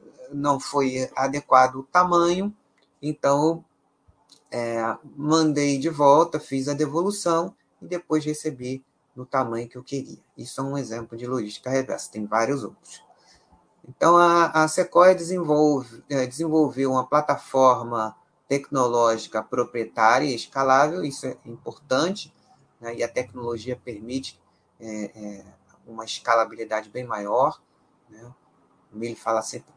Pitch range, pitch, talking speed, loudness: 115-150 Hz, 130 Hz, 125 wpm, -23 LUFS